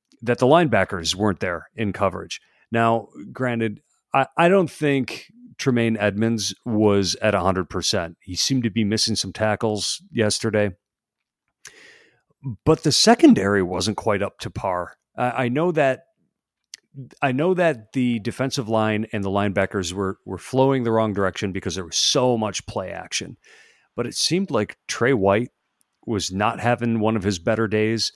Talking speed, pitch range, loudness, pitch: 160 wpm, 100-130 Hz, -21 LUFS, 110 Hz